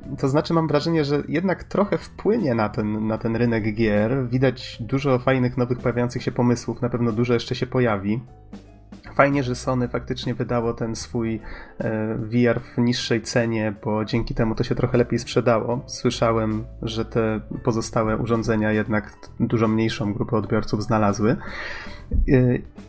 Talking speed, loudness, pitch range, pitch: 150 wpm, -23 LUFS, 110-125 Hz, 115 Hz